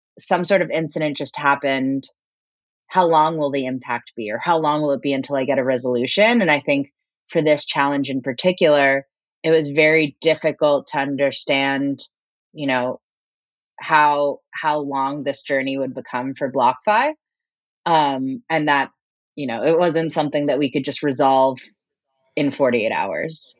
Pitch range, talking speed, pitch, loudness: 135-160 Hz, 165 wpm, 145 Hz, -19 LUFS